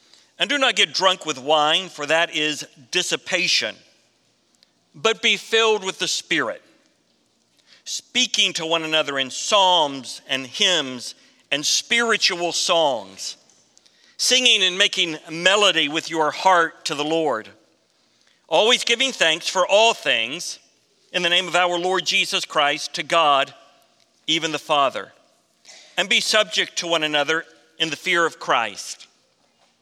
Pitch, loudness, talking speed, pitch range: 175 Hz, -19 LUFS, 135 wpm, 155-200 Hz